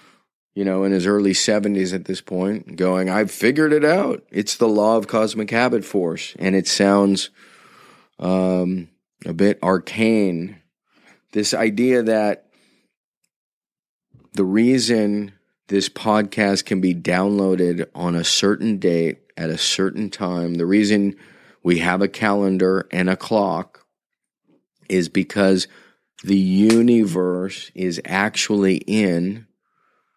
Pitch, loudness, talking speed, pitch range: 100 Hz, -19 LUFS, 125 wpm, 95-105 Hz